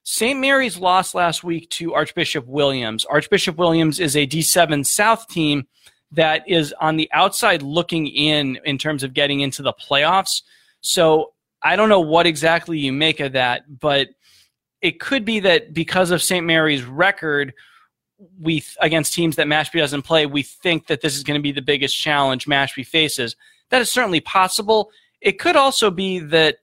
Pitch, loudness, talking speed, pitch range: 160 Hz, -18 LUFS, 175 wpm, 145-185 Hz